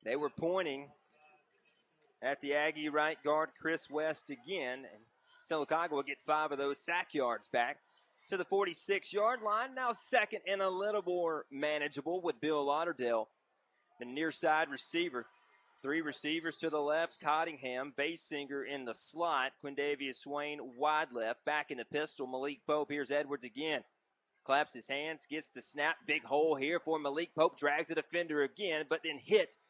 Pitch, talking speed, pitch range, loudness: 150 Hz, 165 wpm, 145-165 Hz, -36 LUFS